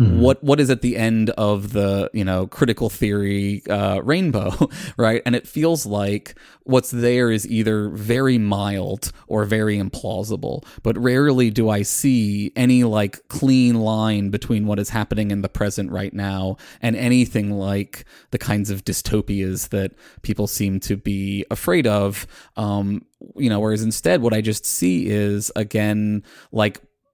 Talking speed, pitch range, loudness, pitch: 160 wpm, 100-120 Hz, -20 LUFS, 105 Hz